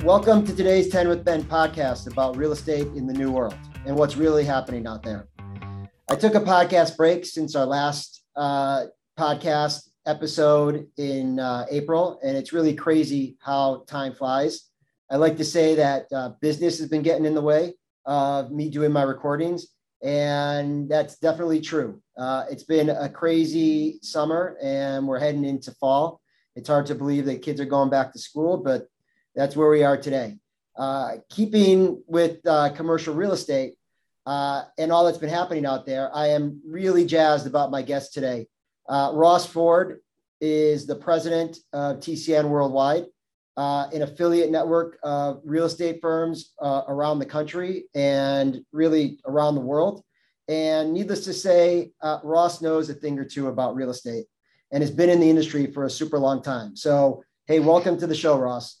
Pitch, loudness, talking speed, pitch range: 150 Hz, -23 LUFS, 175 wpm, 140-165 Hz